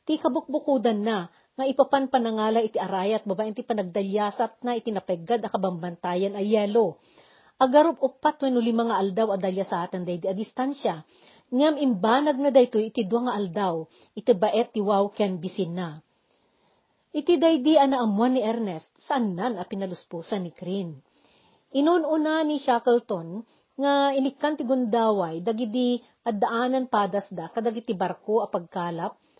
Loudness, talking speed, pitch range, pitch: -25 LUFS, 145 wpm, 195-260 Hz, 225 Hz